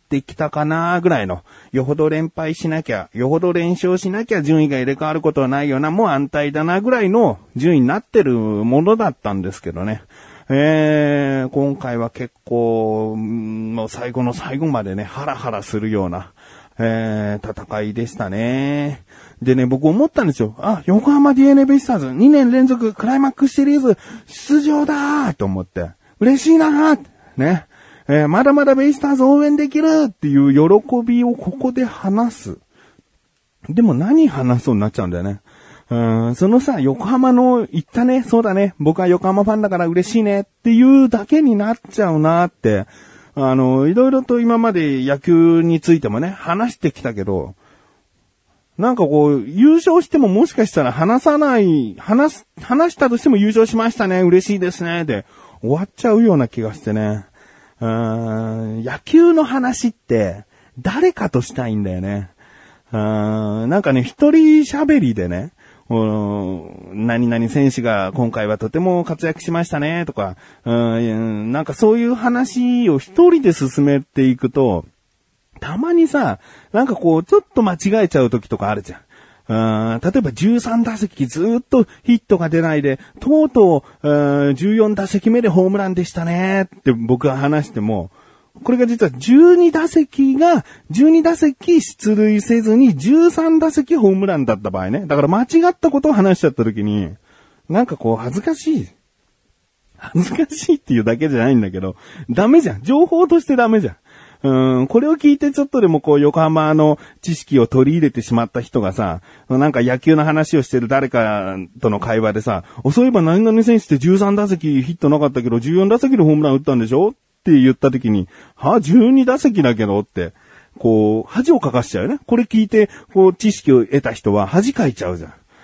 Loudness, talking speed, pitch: -15 LUFS, 335 characters per minute, 160 Hz